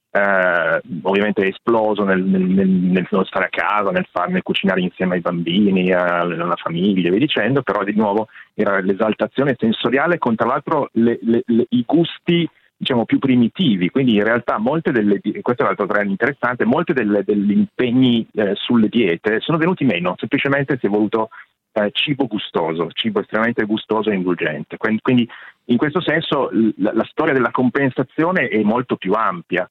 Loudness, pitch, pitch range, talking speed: -18 LUFS, 110 Hz, 100-130 Hz, 165 wpm